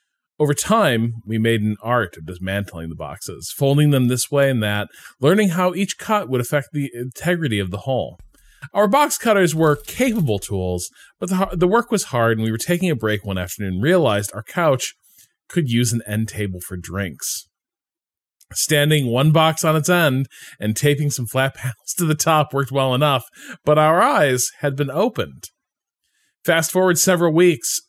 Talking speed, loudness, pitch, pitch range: 185 wpm, -19 LUFS, 135 Hz, 110-165 Hz